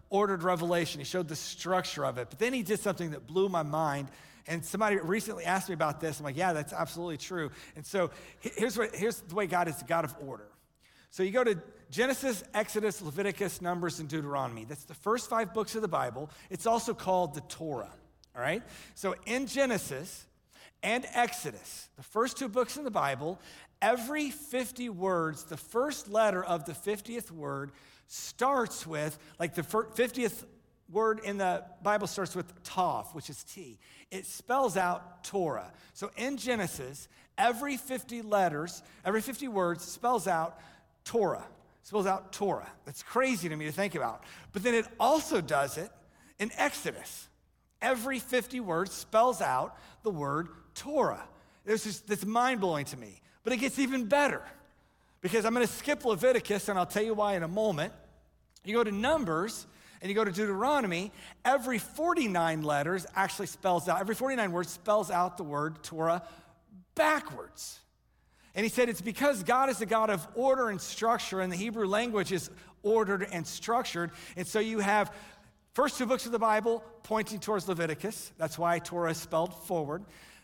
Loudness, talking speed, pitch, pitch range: -32 LUFS, 175 wpm, 200 Hz, 170-230 Hz